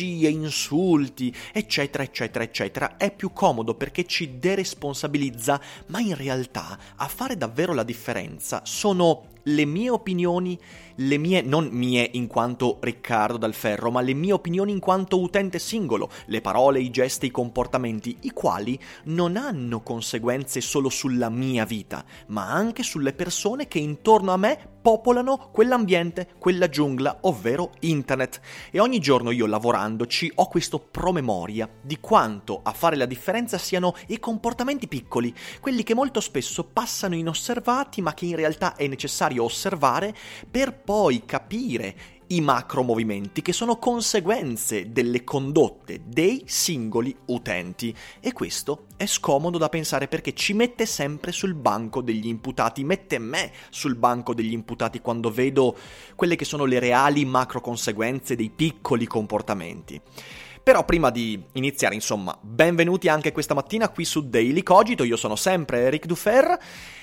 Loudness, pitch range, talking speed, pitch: -24 LUFS, 120-180 Hz, 145 wpm, 145 Hz